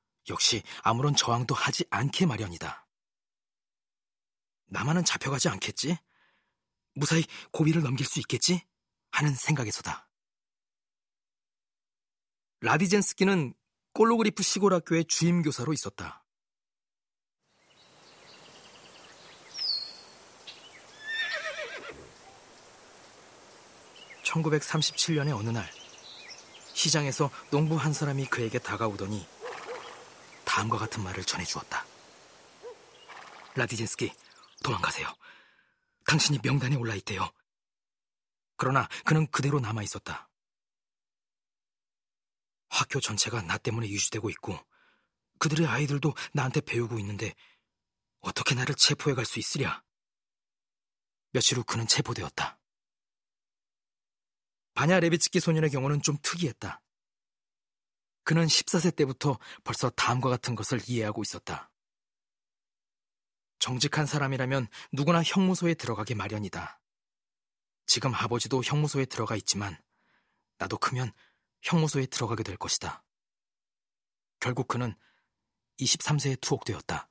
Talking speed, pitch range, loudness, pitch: 230 characters per minute, 115-160 Hz, -28 LUFS, 140 Hz